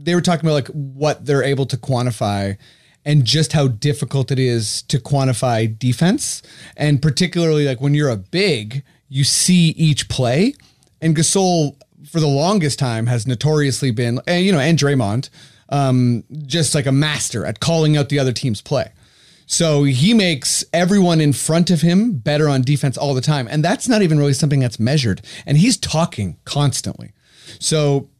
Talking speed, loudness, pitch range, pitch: 175 wpm, -17 LUFS, 130-160 Hz, 145 Hz